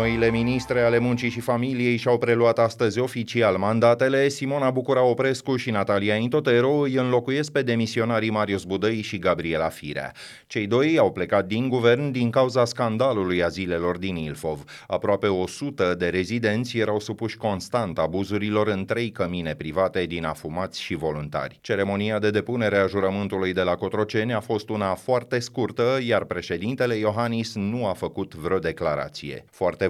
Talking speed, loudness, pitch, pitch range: 155 wpm, -24 LUFS, 110 Hz, 95-120 Hz